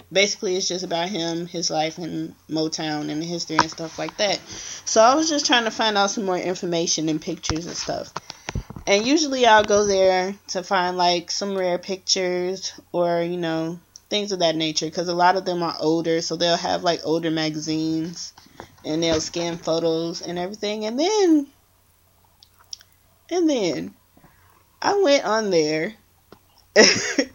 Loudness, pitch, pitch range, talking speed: -22 LUFS, 175 Hz, 160-200 Hz, 165 wpm